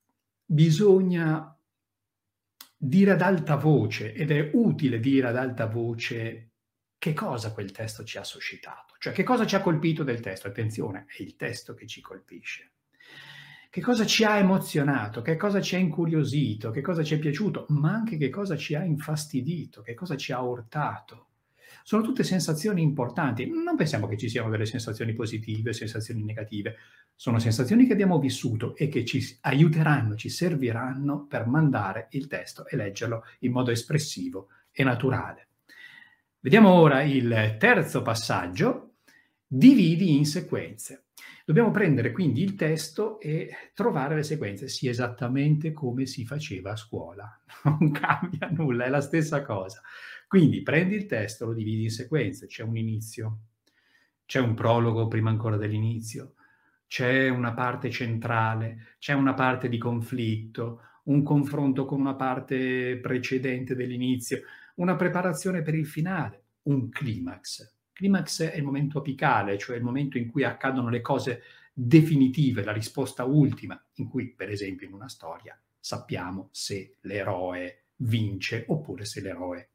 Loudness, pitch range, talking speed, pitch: -26 LUFS, 115-155 Hz, 150 wpm, 130 Hz